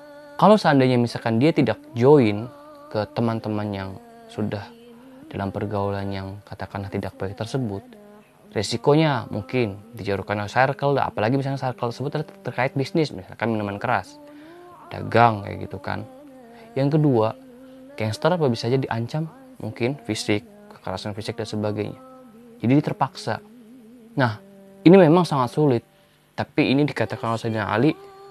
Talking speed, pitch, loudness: 130 wpm, 125 Hz, -22 LUFS